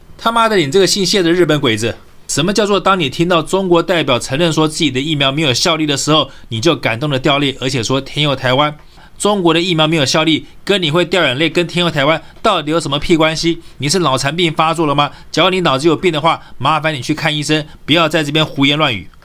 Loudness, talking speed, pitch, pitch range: -14 LUFS, 360 characters per minute, 160 Hz, 145-170 Hz